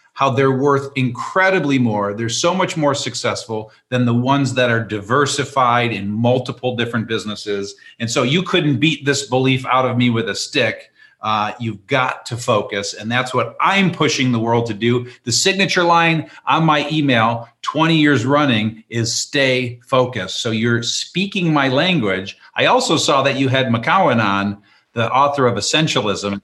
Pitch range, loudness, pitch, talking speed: 115-140 Hz, -17 LUFS, 125 Hz, 170 wpm